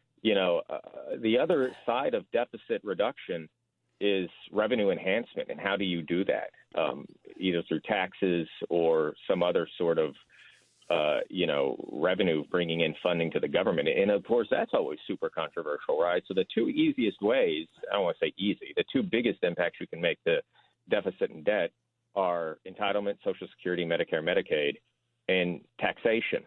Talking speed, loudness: 165 wpm, -30 LUFS